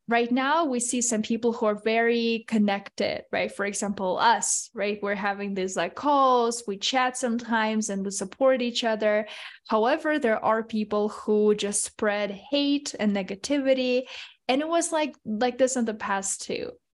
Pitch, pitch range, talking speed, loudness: 225 Hz, 205-255 Hz, 170 wpm, -25 LUFS